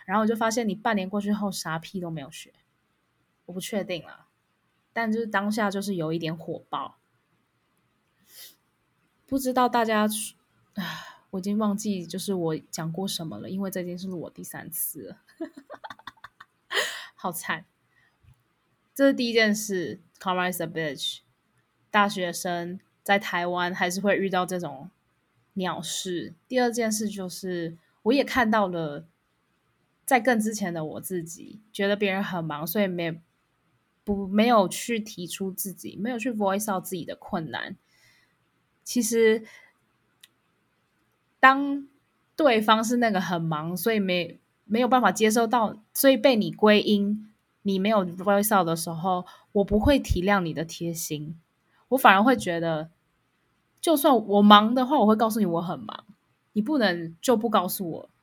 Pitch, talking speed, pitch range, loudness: 200 Hz, 235 characters per minute, 175-225 Hz, -25 LUFS